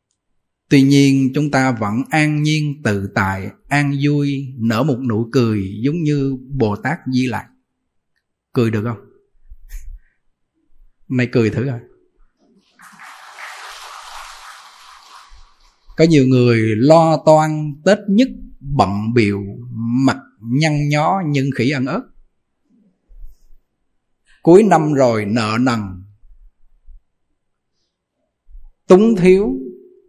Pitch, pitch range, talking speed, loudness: 135 Hz, 115-155 Hz, 100 wpm, -16 LUFS